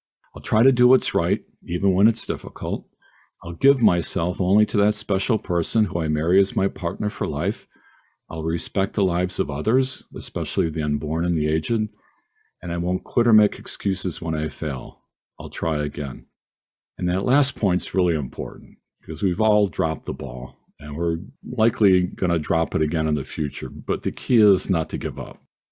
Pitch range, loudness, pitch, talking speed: 80-105 Hz, -23 LUFS, 90 Hz, 190 wpm